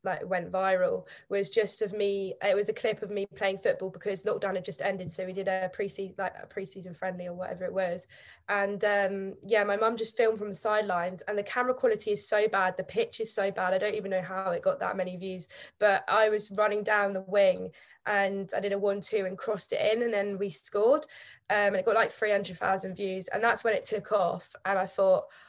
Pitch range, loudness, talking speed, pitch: 190-215 Hz, -29 LUFS, 245 wpm, 200 Hz